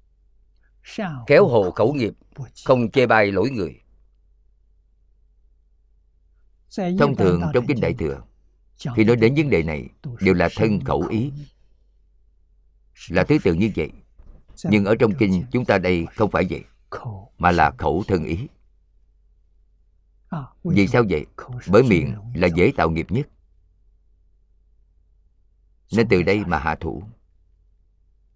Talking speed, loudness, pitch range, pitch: 130 wpm, -20 LUFS, 80-100 Hz, 85 Hz